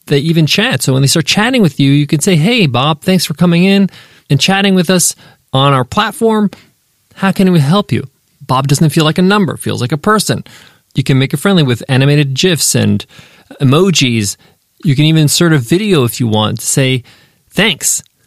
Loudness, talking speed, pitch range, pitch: -11 LUFS, 205 wpm, 135-185 Hz, 155 Hz